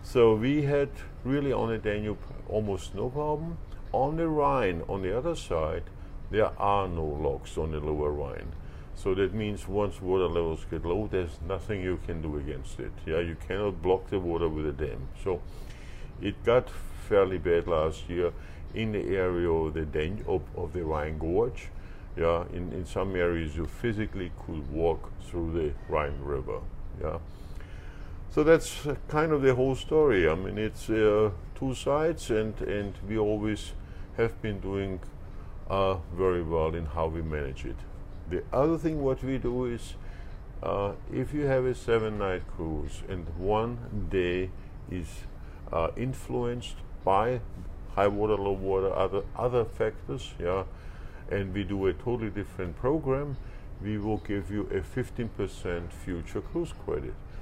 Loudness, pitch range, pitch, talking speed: -30 LUFS, 85-110 Hz, 95 Hz, 160 wpm